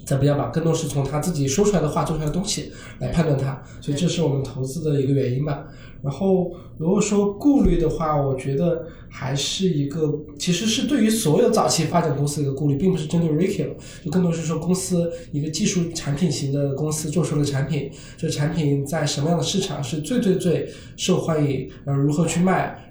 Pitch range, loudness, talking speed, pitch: 140-175 Hz, -22 LUFS, 340 characters per minute, 155 Hz